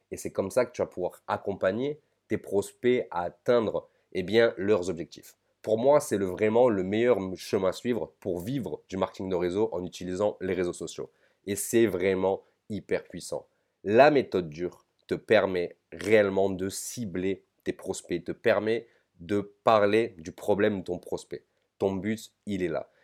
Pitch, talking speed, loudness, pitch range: 105 Hz, 175 wpm, -28 LUFS, 95-115 Hz